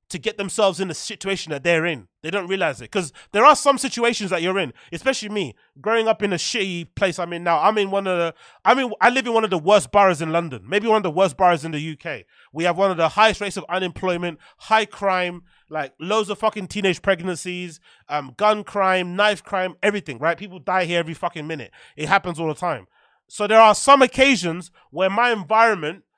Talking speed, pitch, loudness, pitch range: 230 wpm, 190 Hz, -20 LUFS, 170-210 Hz